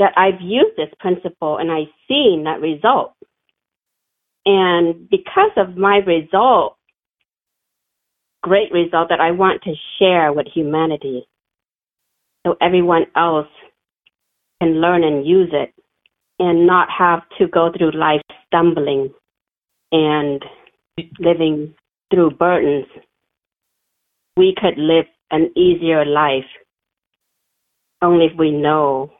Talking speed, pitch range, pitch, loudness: 110 wpm, 155-185 Hz, 170 Hz, -16 LUFS